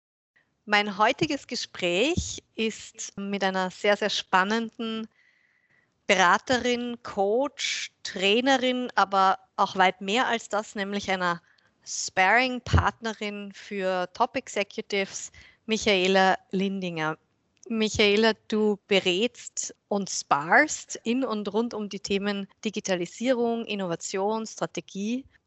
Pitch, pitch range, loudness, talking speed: 210 Hz, 195-230 Hz, -26 LUFS, 90 wpm